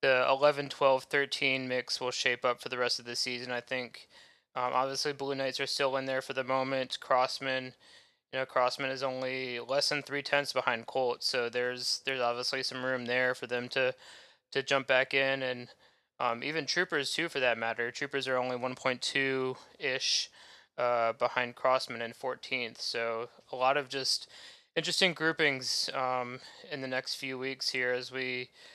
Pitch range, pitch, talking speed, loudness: 125-135 Hz, 130 Hz, 180 wpm, -31 LUFS